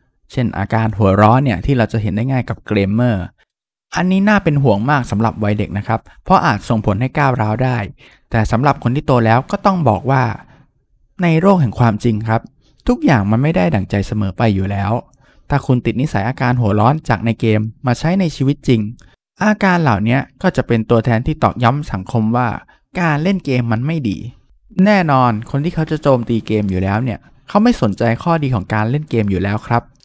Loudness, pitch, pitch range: -16 LUFS, 120 Hz, 110-140 Hz